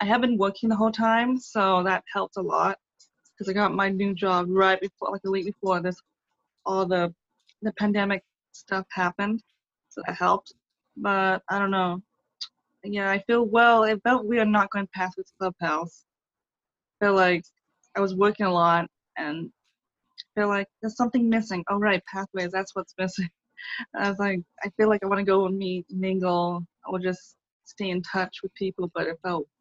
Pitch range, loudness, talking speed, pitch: 185-215 Hz, -25 LUFS, 200 wpm, 195 Hz